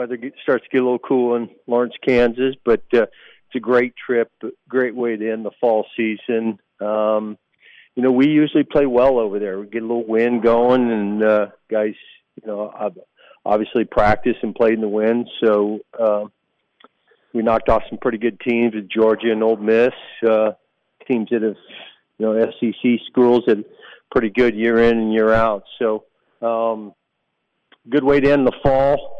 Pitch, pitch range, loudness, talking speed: 115 Hz, 110-125 Hz, -19 LUFS, 180 wpm